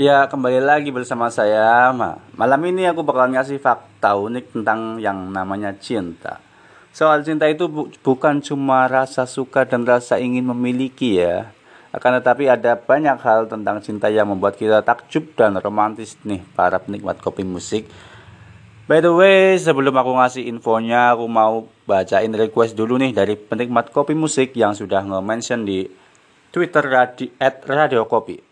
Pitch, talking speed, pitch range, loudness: 120 Hz, 155 wpm, 110-135 Hz, -18 LUFS